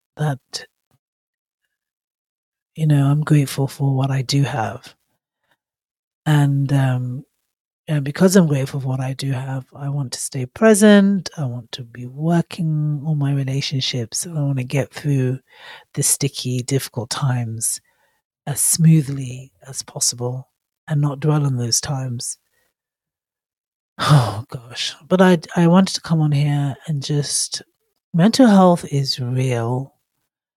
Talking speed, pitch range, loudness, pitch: 135 wpm, 130-155 Hz, -19 LUFS, 140 Hz